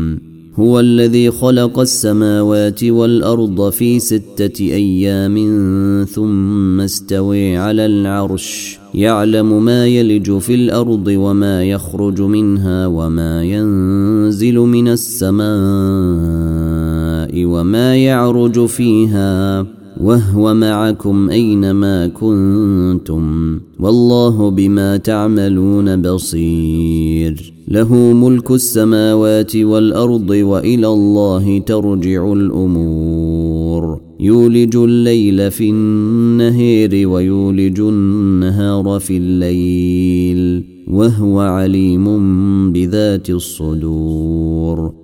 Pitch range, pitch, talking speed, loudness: 90-110 Hz, 100 Hz, 75 wpm, -13 LUFS